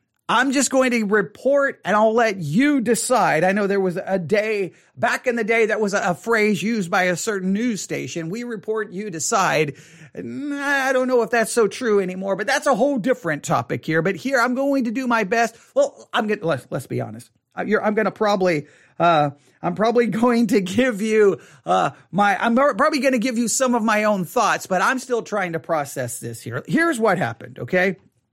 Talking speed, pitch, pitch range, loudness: 220 wpm, 215 Hz, 180-245 Hz, -20 LUFS